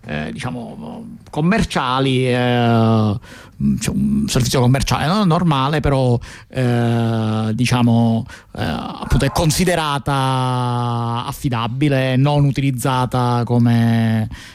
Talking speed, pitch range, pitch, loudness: 80 wpm, 115-145 Hz, 125 Hz, -17 LUFS